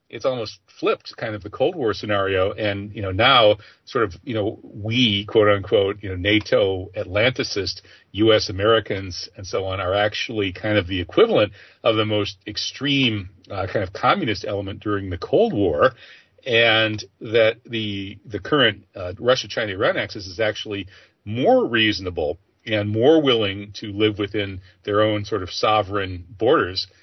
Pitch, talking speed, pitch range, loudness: 105 Hz, 165 wpm, 100-110 Hz, -21 LUFS